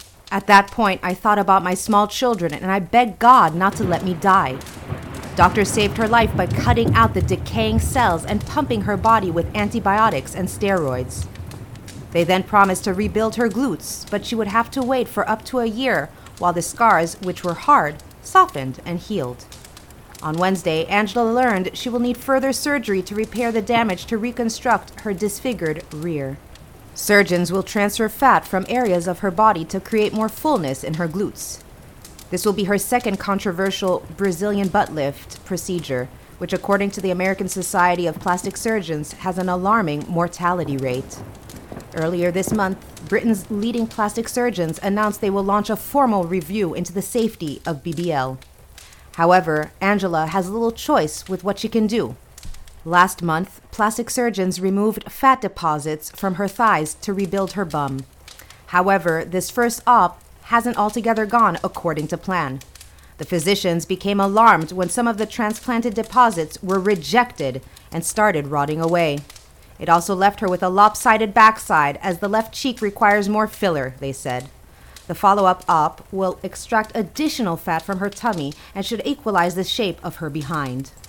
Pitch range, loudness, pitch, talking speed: 165-220 Hz, -19 LUFS, 195 Hz, 165 wpm